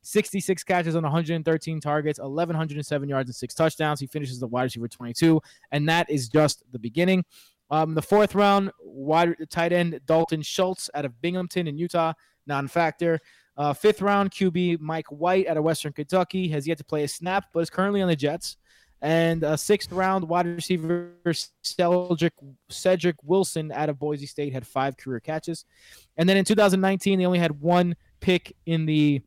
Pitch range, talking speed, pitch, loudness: 150-180 Hz, 180 wpm, 165 Hz, -25 LUFS